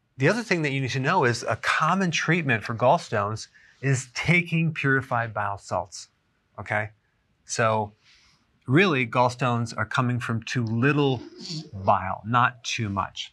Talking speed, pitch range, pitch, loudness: 145 wpm, 110-150 Hz, 125 Hz, -24 LUFS